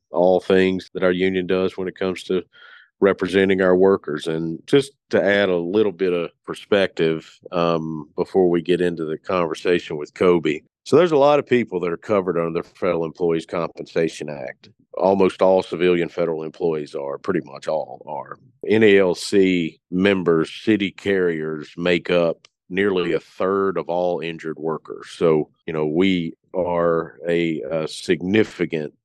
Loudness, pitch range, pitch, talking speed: -20 LUFS, 80-95 Hz, 90 Hz, 160 wpm